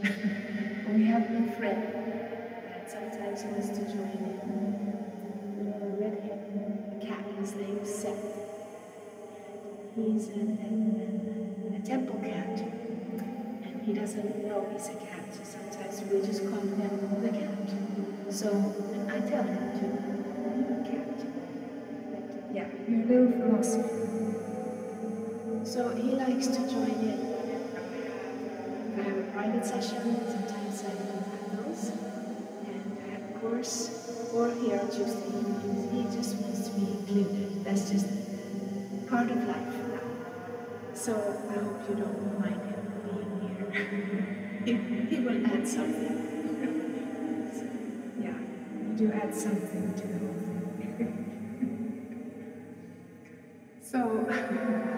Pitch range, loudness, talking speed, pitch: 205-235 Hz, -33 LUFS, 115 wpm, 215 Hz